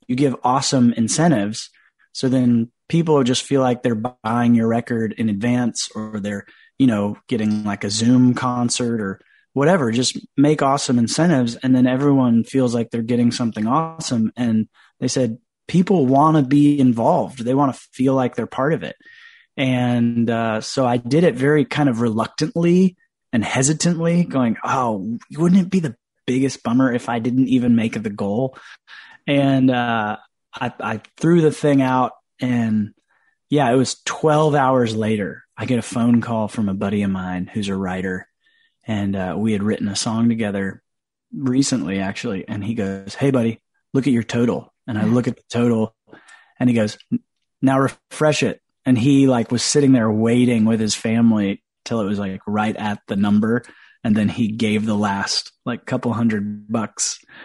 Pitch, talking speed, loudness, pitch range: 120 Hz, 180 wpm, -19 LUFS, 110-135 Hz